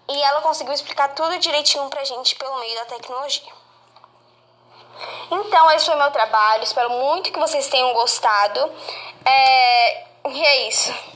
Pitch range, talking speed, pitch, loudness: 255-320 Hz, 145 wpm, 285 Hz, -17 LUFS